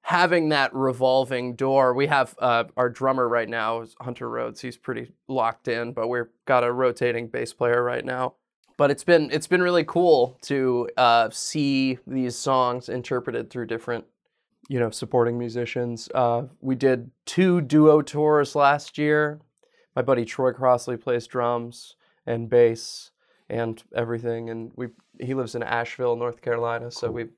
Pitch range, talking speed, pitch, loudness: 120-135 Hz, 160 wpm, 125 Hz, -23 LUFS